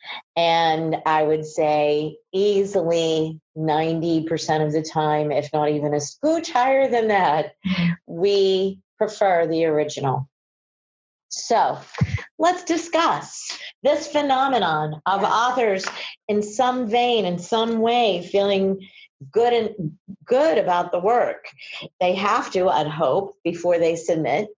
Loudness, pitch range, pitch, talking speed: -21 LUFS, 155-215 Hz, 180 Hz, 120 wpm